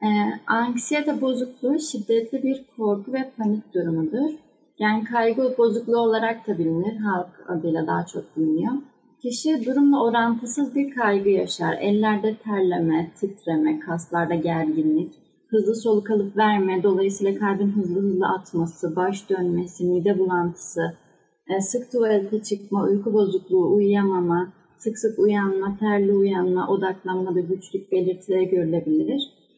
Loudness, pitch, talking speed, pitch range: -23 LUFS, 205 Hz, 125 wpm, 185-235 Hz